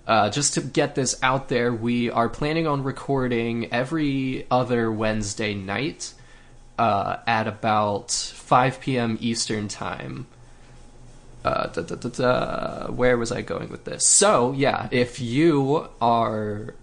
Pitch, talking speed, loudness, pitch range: 120 Hz, 140 wpm, -23 LUFS, 115-130 Hz